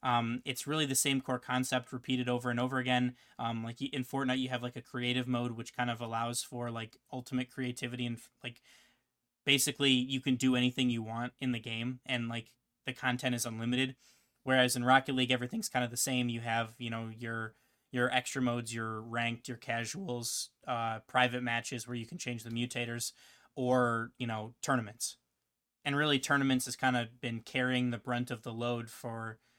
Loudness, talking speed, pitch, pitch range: -34 LUFS, 195 wpm, 125 Hz, 115-130 Hz